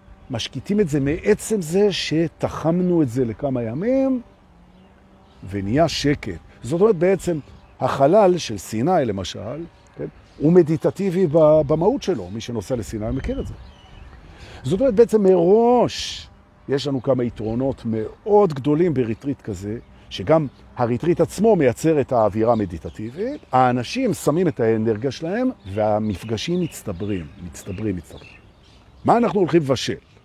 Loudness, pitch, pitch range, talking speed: -20 LUFS, 135 Hz, 105-175 Hz, 125 wpm